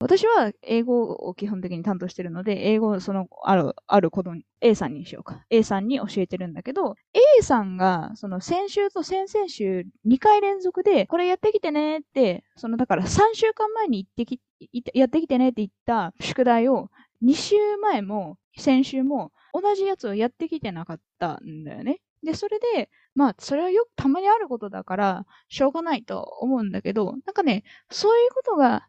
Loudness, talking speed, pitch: -23 LUFS, 355 characters per minute, 255 Hz